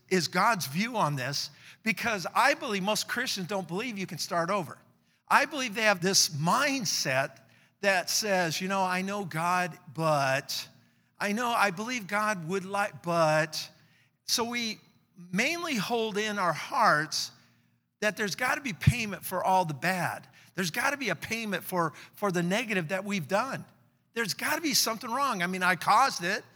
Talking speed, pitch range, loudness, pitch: 180 wpm, 165-215 Hz, -28 LUFS, 190 Hz